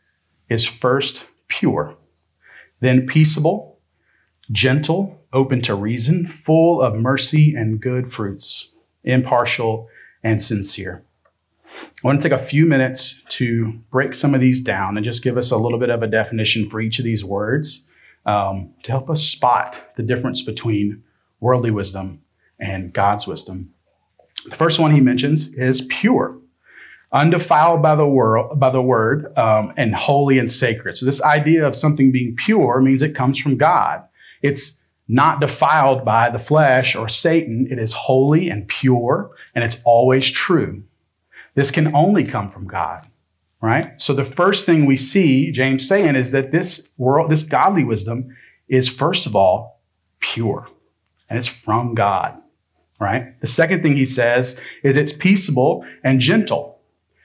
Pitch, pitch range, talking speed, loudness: 130 Hz, 110-145 Hz, 155 wpm, -18 LUFS